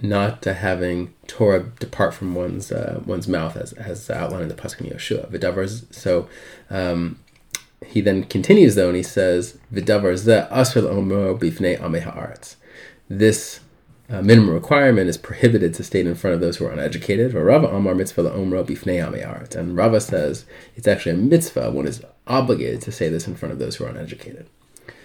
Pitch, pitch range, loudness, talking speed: 100 Hz, 90-110 Hz, -20 LUFS, 160 wpm